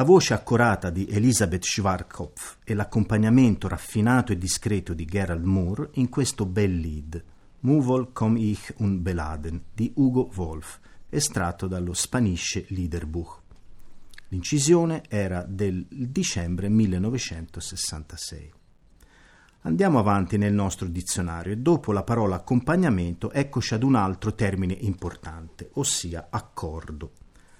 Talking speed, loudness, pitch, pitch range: 115 wpm, -25 LUFS, 100 Hz, 85-115 Hz